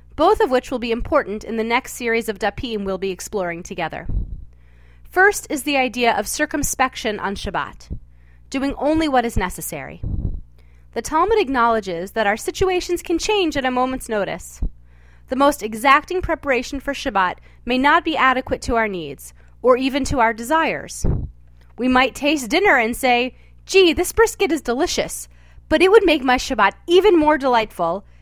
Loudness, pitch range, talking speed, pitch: -19 LUFS, 190-300 Hz, 170 wpm, 250 Hz